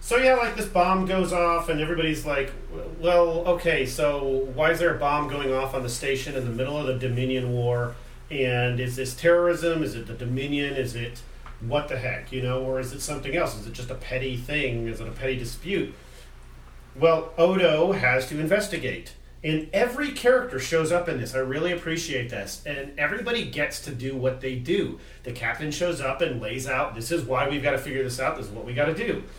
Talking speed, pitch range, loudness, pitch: 220 wpm, 125-165 Hz, -25 LUFS, 135 Hz